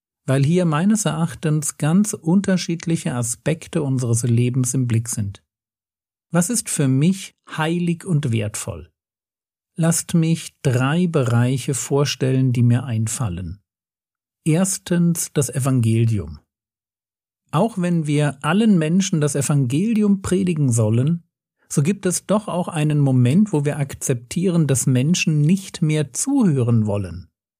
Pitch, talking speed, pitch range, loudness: 145 Hz, 120 wpm, 120-170 Hz, -20 LUFS